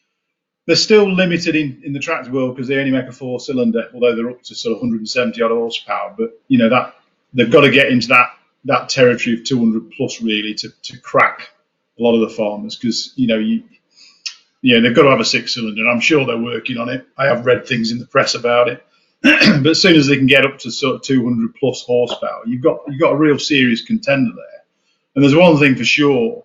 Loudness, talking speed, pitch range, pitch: -15 LUFS, 235 wpm, 120-165 Hz, 130 Hz